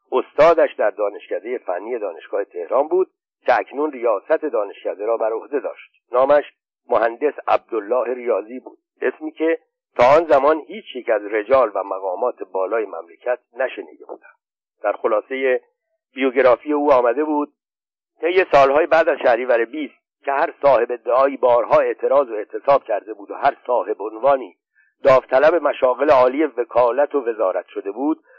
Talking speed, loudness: 145 wpm, -19 LUFS